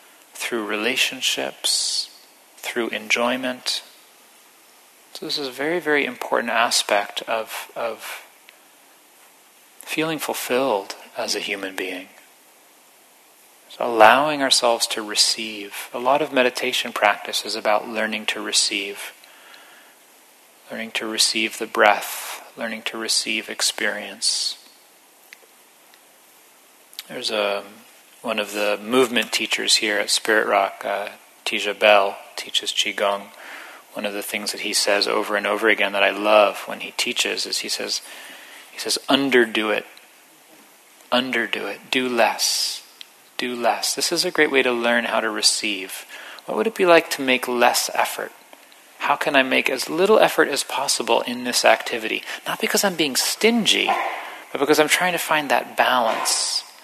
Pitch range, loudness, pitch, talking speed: 105-140 Hz, -20 LUFS, 120 Hz, 145 wpm